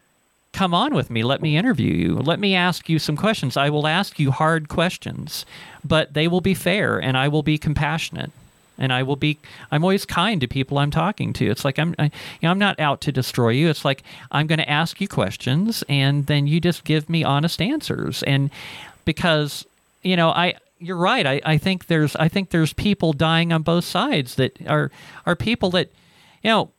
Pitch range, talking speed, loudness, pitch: 140-175 Hz, 215 wpm, -21 LUFS, 155 Hz